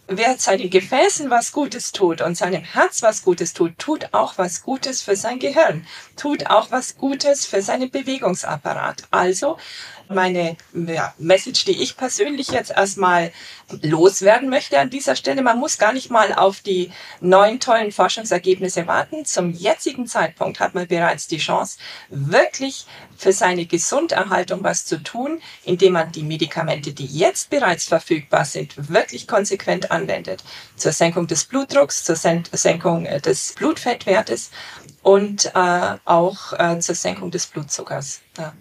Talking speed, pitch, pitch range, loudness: 150 wpm, 190 Hz, 170-255 Hz, -19 LUFS